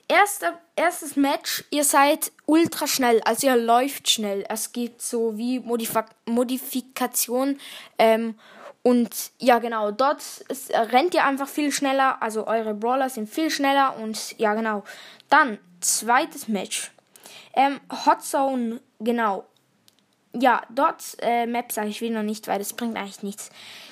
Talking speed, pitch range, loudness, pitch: 145 wpm, 225-285 Hz, -23 LUFS, 245 Hz